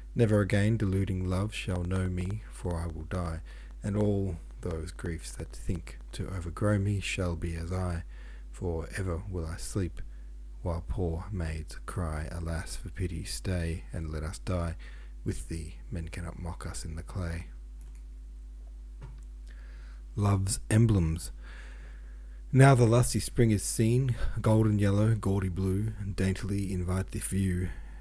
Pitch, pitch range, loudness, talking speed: 90 Hz, 75-100 Hz, -31 LUFS, 145 wpm